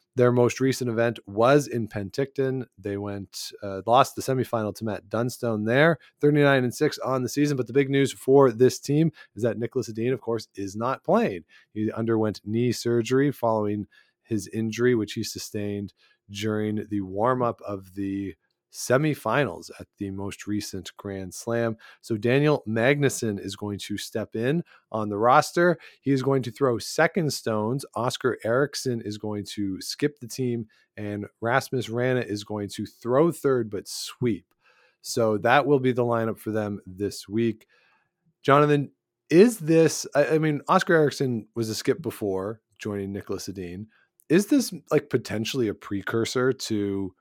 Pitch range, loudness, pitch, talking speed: 105-135 Hz, -25 LUFS, 115 Hz, 165 wpm